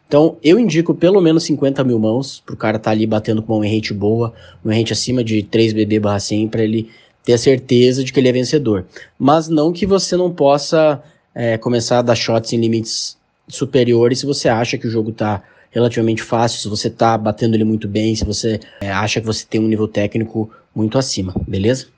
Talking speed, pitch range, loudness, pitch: 215 wpm, 110-135 Hz, -16 LUFS, 115 Hz